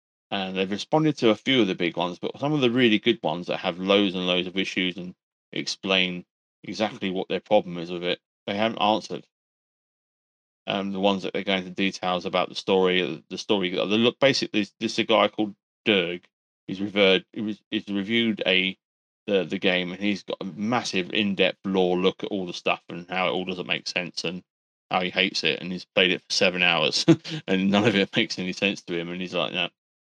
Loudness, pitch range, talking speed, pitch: -24 LUFS, 90-105 Hz, 220 wpm, 95 Hz